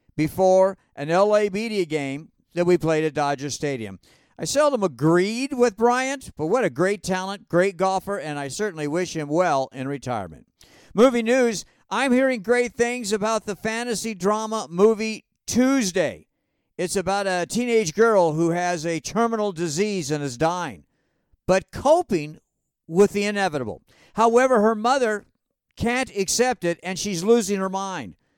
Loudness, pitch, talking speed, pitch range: -22 LUFS, 195 Hz, 150 wpm, 170-225 Hz